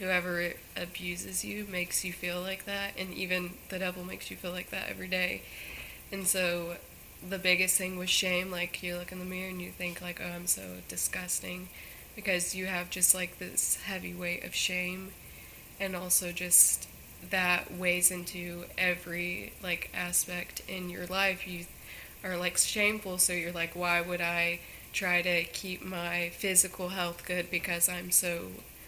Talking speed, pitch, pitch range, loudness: 170 wpm, 180 Hz, 175-185 Hz, -30 LUFS